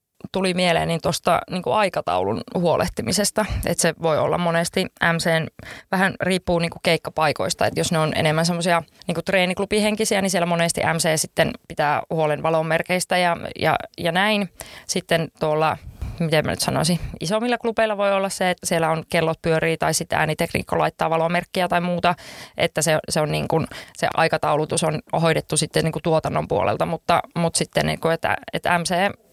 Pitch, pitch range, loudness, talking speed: 170 Hz, 160-185 Hz, -21 LUFS, 165 wpm